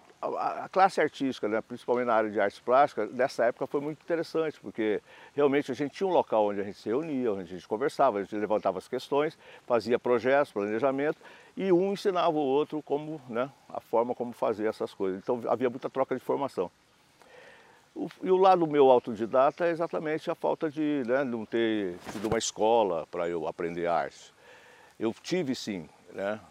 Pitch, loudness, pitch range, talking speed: 135 Hz, -29 LUFS, 115-160 Hz, 185 wpm